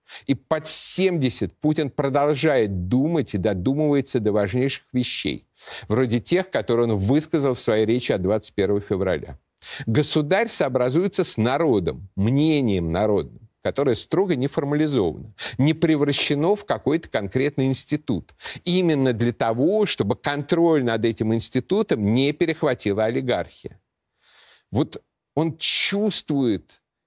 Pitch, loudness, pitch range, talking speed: 135 Hz, -22 LUFS, 115-155 Hz, 115 wpm